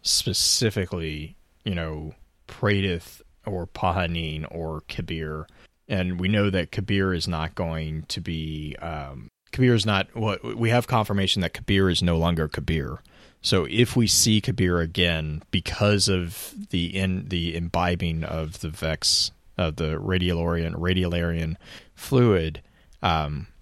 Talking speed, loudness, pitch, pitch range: 135 wpm, -24 LUFS, 90 Hz, 80-100 Hz